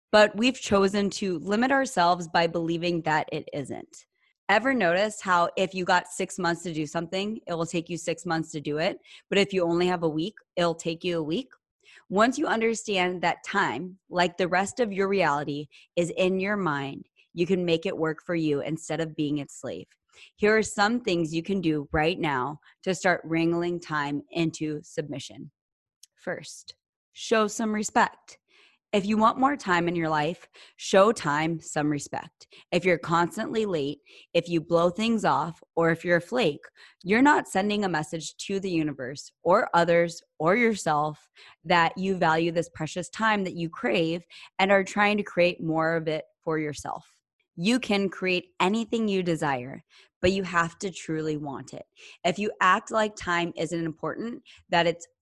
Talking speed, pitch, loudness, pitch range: 185 wpm, 175 Hz, -26 LUFS, 160-195 Hz